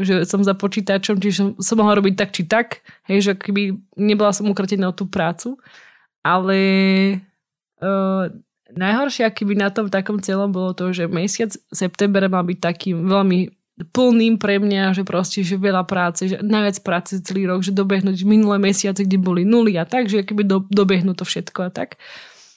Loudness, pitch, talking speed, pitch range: -18 LUFS, 195 Hz, 180 wpm, 185-205 Hz